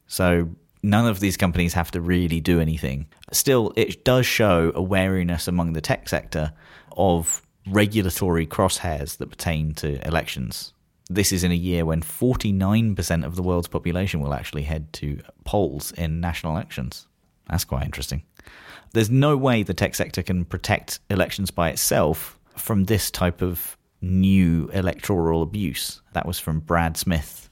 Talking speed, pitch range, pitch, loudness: 155 wpm, 80-95 Hz, 85 Hz, -23 LUFS